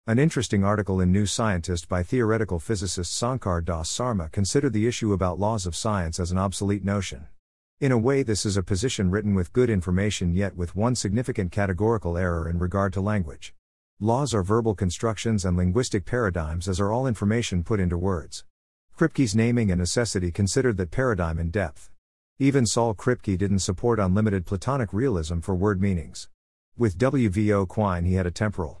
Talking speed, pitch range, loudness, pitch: 180 wpm, 90-115 Hz, -25 LUFS, 100 Hz